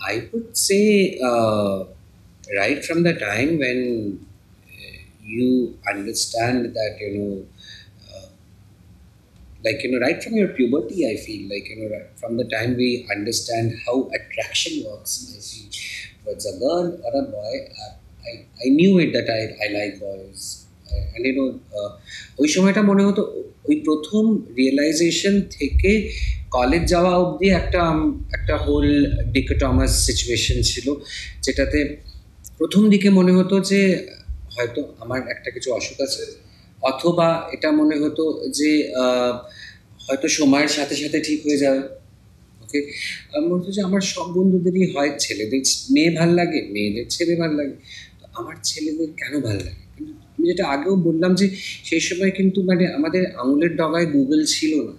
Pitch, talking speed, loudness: 145 Hz, 145 wpm, -20 LUFS